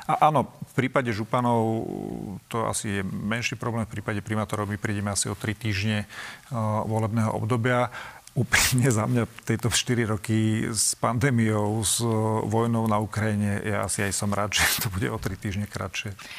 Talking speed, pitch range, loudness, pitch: 170 wpm, 105-115 Hz, -25 LUFS, 110 Hz